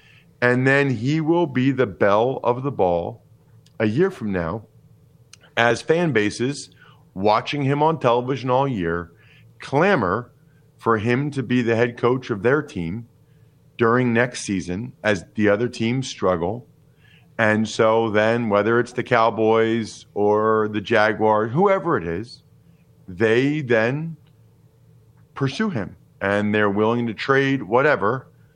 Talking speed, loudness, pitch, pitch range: 135 wpm, -21 LUFS, 120 Hz, 110-140 Hz